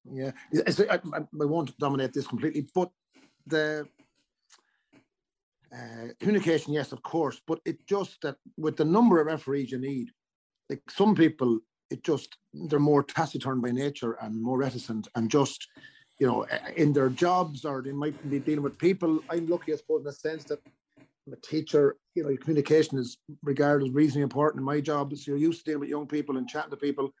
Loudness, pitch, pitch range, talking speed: -28 LUFS, 145 Hz, 135-155 Hz, 195 wpm